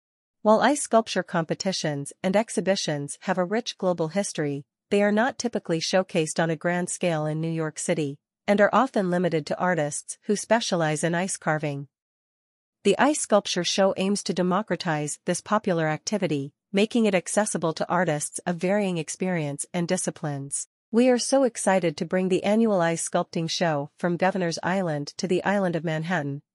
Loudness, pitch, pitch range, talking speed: -25 LUFS, 180 Hz, 160-200 Hz, 165 wpm